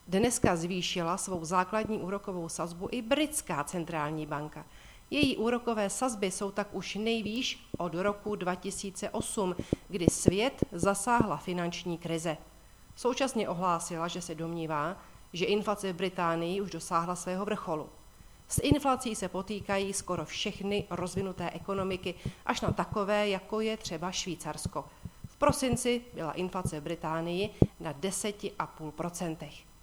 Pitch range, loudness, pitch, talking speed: 170-205 Hz, -32 LUFS, 185 Hz, 125 wpm